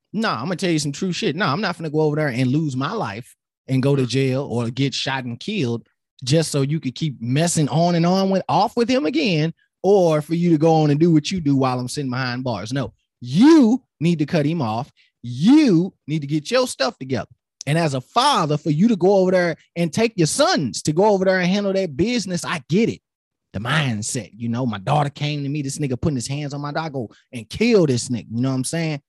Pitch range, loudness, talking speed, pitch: 130-175 Hz, -20 LUFS, 260 wpm, 155 Hz